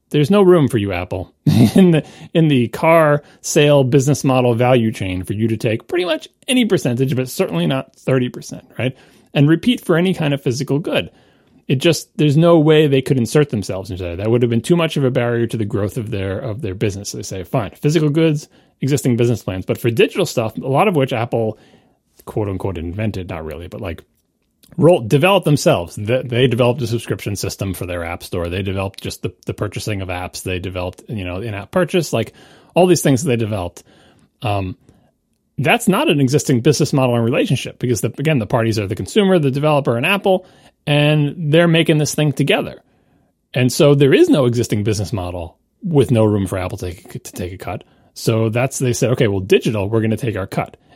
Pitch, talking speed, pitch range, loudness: 125 Hz, 210 wpm, 105-150 Hz, -17 LUFS